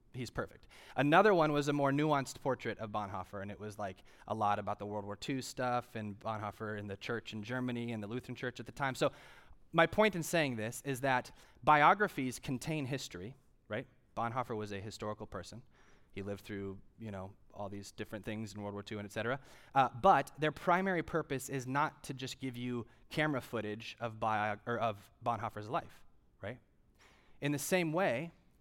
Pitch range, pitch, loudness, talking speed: 105-135 Hz, 120 Hz, -36 LUFS, 195 wpm